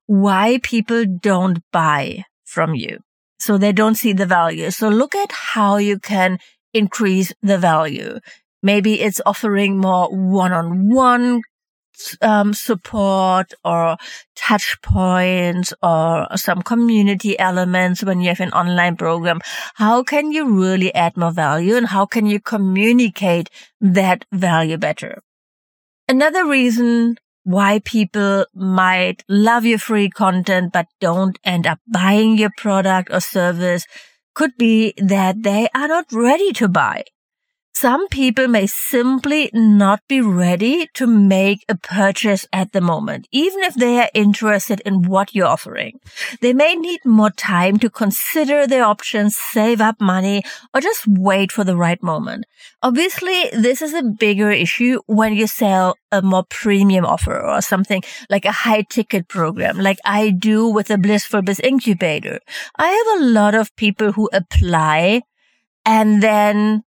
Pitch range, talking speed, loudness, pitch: 185-230 Hz, 145 wpm, -16 LUFS, 205 Hz